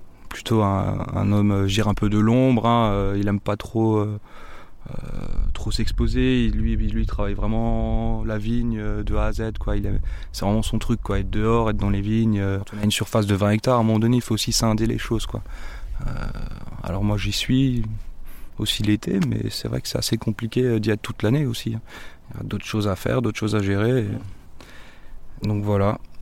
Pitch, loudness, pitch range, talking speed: 105 Hz, -23 LUFS, 100-115 Hz, 220 wpm